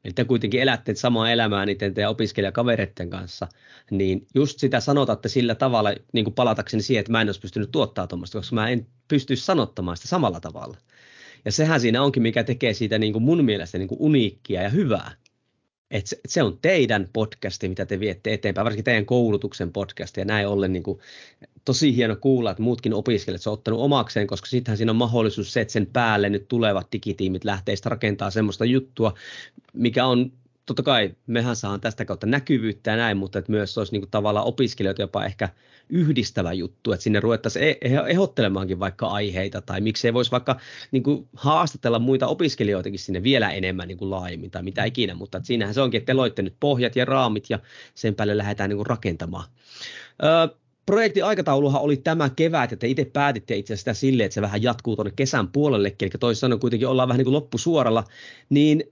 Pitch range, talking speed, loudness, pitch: 100-130 Hz, 190 wpm, -23 LUFS, 115 Hz